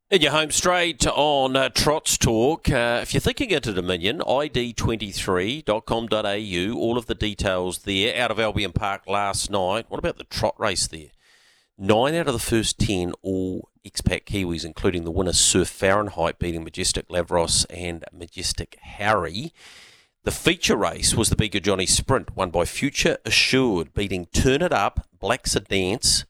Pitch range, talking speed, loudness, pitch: 90-120 Hz, 160 wpm, -22 LUFS, 100 Hz